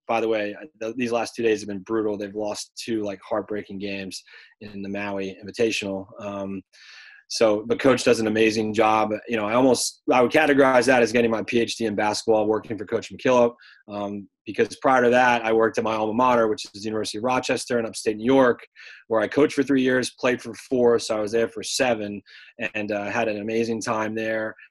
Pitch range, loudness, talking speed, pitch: 105-120 Hz, -23 LUFS, 215 wpm, 110 Hz